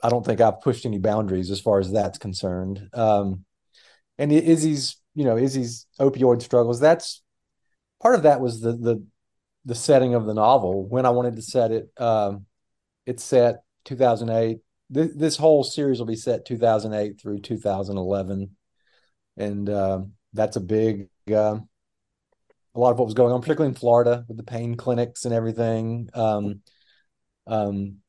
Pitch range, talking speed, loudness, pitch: 100-125 Hz, 160 wpm, -22 LUFS, 115 Hz